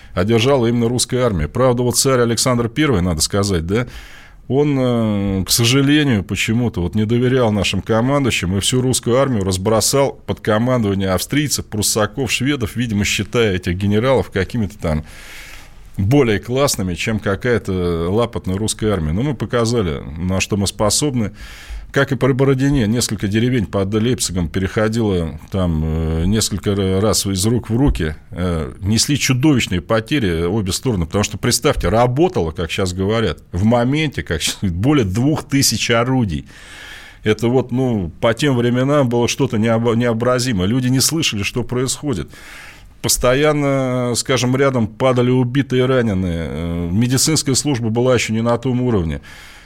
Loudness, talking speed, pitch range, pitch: -17 LUFS, 145 wpm, 95-125 Hz, 115 Hz